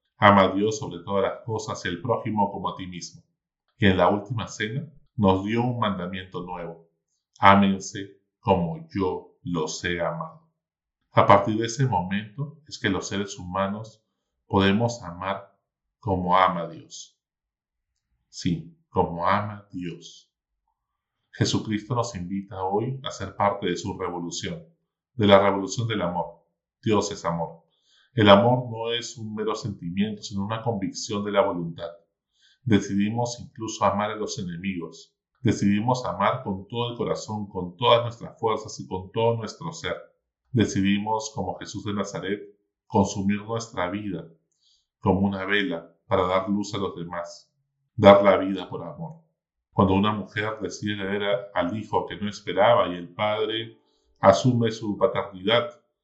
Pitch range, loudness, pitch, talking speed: 95-115 Hz, -25 LUFS, 100 Hz, 150 wpm